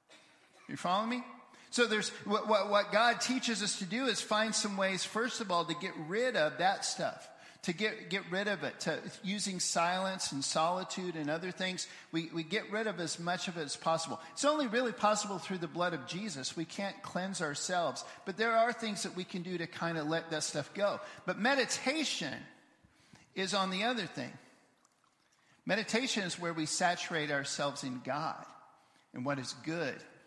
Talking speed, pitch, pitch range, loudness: 195 wpm, 190 Hz, 170-220 Hz, -34 LUFS